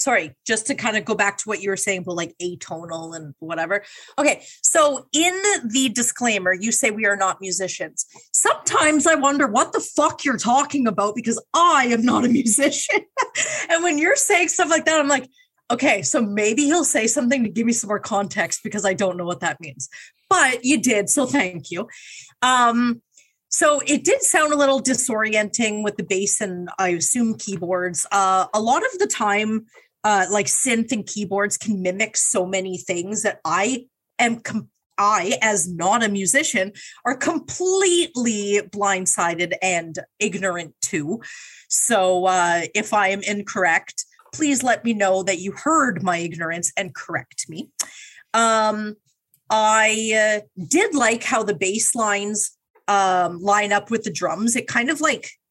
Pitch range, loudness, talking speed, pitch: 195-275 Hz, -20 LUFS, 175 wpm, 215 Hz